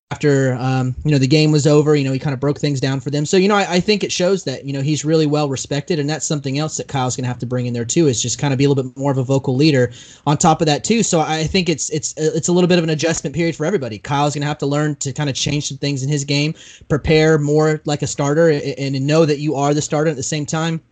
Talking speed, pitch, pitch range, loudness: 315 wpm, 150 Hz, 140-155 Hz, -17 LUFS